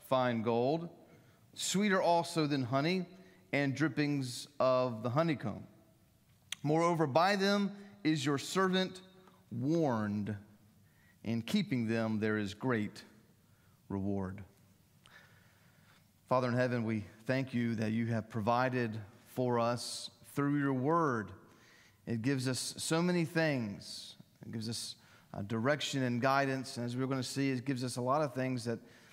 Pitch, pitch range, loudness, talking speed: 125 Hz, 115-150 Hz, -34 LUFS, 140 wpm